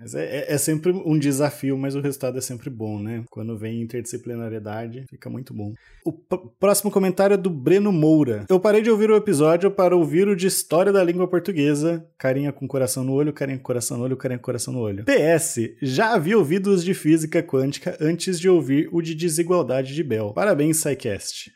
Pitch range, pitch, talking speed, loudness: 130-180 Hz, 150 Hz, 205 wpm, -21 LUFS